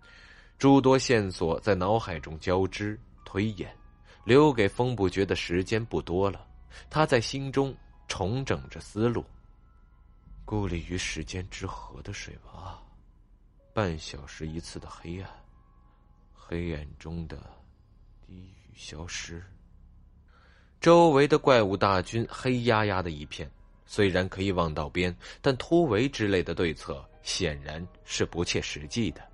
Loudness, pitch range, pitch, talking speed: -27 LUFS, 80-110 Hz, 95 Hz, 190 characters per minute